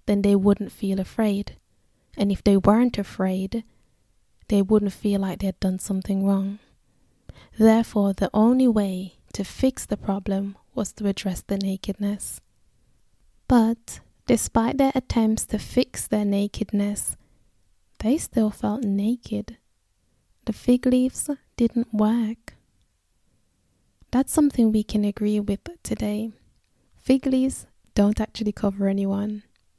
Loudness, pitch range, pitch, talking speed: -23 LUFS, 200-230 Hz, 210 Hz, 125 wpm